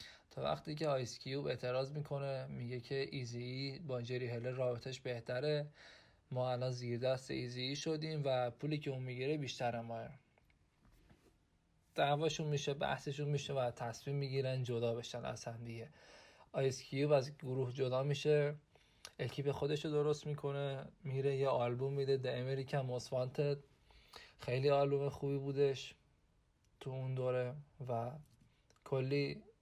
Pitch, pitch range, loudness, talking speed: 135 Hz, 125-140 Hz, -39 LUFS, 140 wpm